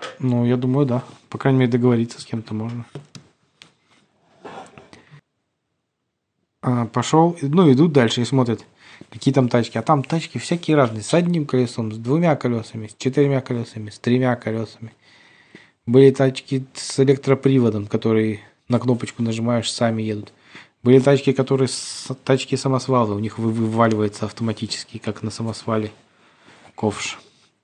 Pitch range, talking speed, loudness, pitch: 115-135 Hz, 135 wpm, -20 LUFS, 125 Hz